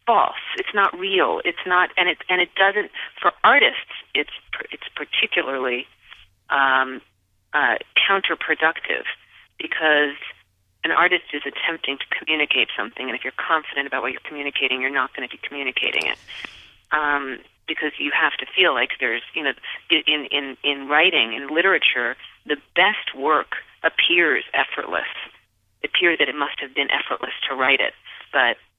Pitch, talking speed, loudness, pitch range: 150 Hz, 155 wpm, -20 LUFS, 135-180 Hz